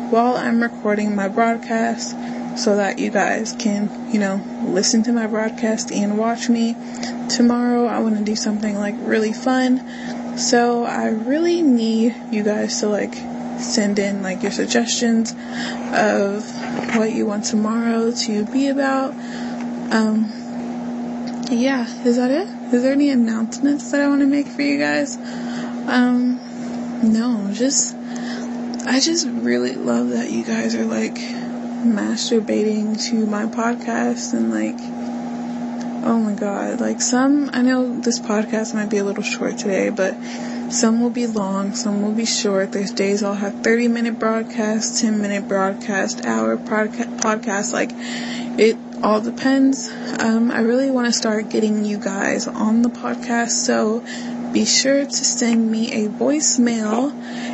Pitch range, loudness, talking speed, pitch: 220-245 Hz, -20 LUFS, 150 wpm, 240 Hz